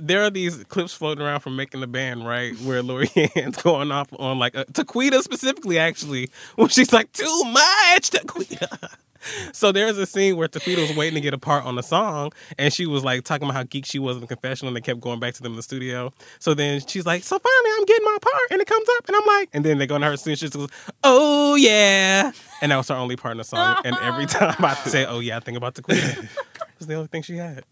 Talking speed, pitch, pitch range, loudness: 265 wpm, 155 Hz, 130-215 Hz, -20 LUFS